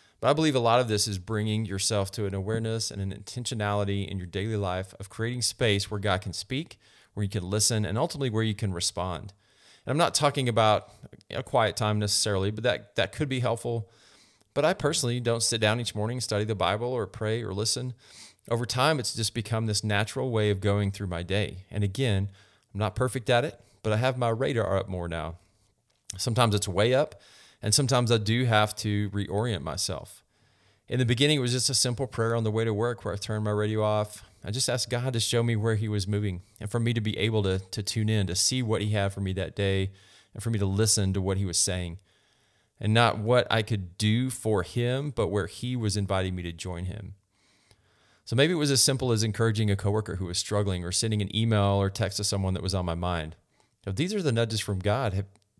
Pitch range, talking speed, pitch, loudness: 100-115 Hz, 235 wpm, 105 Hz, -27 LUFS